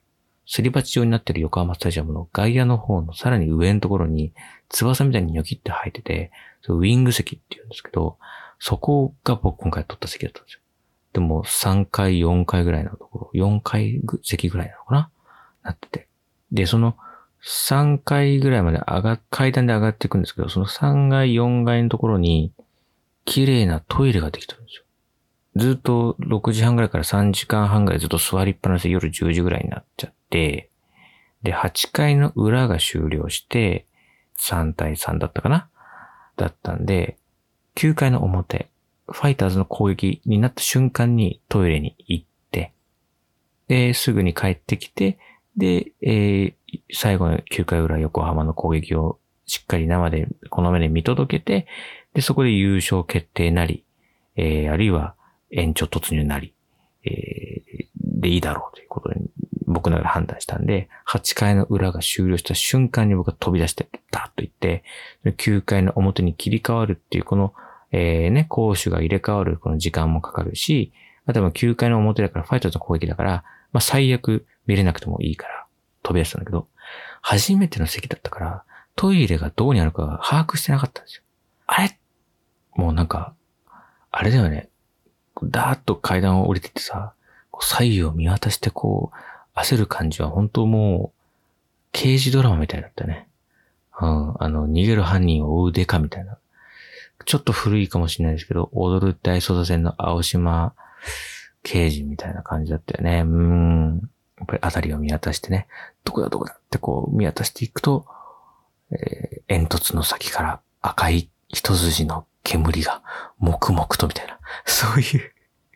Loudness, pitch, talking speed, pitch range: -21 LUFS, 95 Hz, 320 characters per minute, 85-115 Hz